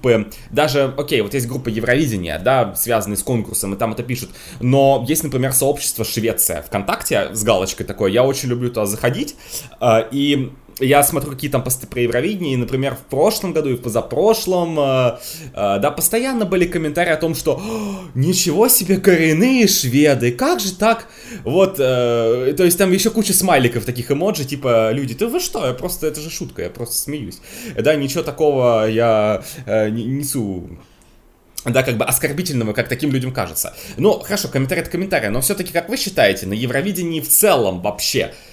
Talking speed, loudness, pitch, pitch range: 175 wpm, -17 LUFS, 135 Hz, 120-175 Hz